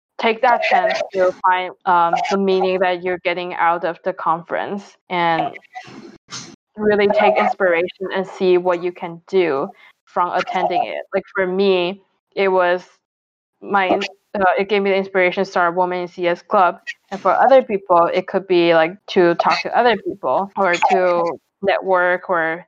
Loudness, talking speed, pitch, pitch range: -18 LUFS, 170 wpm, 185 Hz, 180-195 Hz